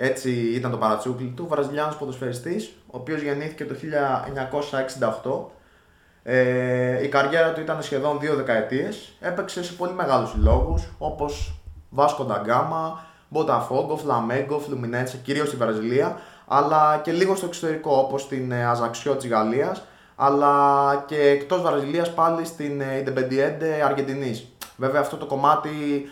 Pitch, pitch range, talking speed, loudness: 140 Hz, 125-150 Hz, 130 wpm, -23 LUFS